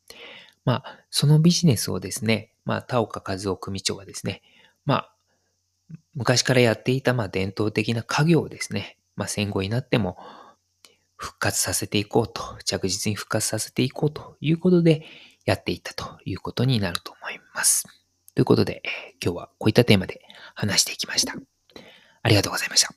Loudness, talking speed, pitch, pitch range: -23 LUFS, 360 characters per minute, 110 Hz, 95-130 Hz